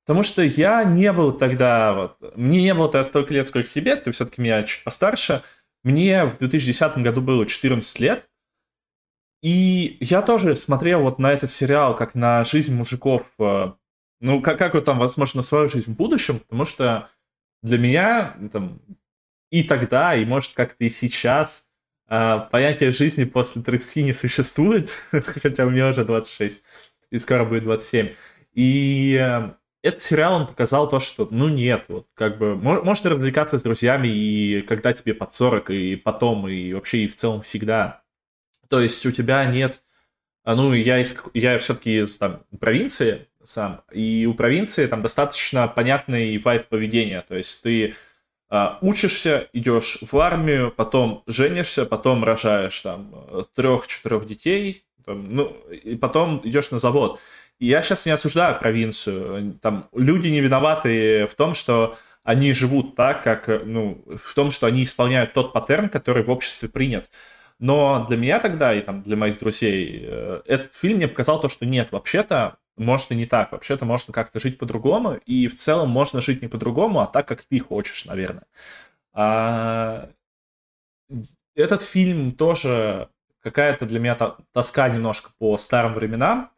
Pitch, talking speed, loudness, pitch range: 125 Hz, 160 wpm, -20 LUFS, 115-145 Hz